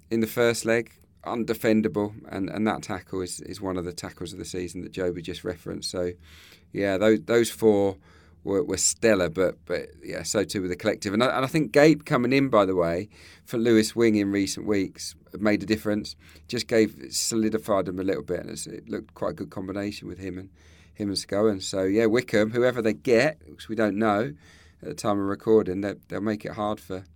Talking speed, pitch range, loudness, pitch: 215 wpm, 90-110 Hz, -25 LUFS, 100 Hz